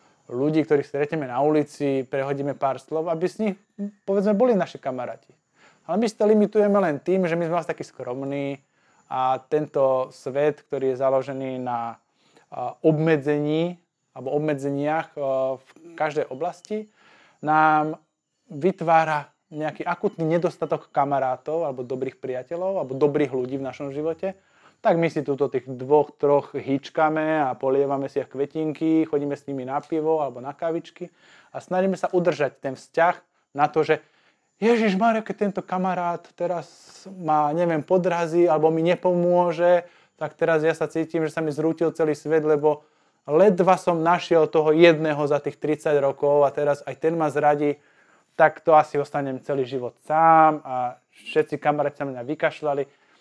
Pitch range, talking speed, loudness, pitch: 140-170 Hz, 155 wpm, -23 LUFS, 155 Hz